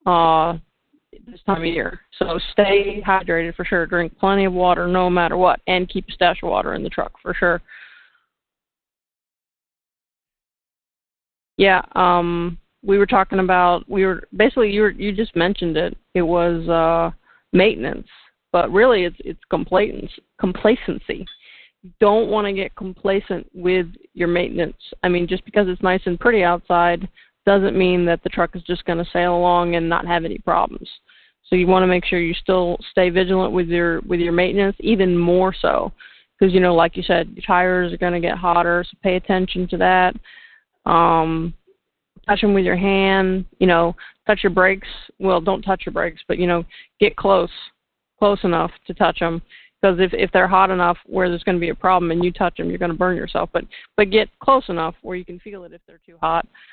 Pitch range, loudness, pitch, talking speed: 175-195 Hz, -18 LUFS, 185 Hz, 195 wpm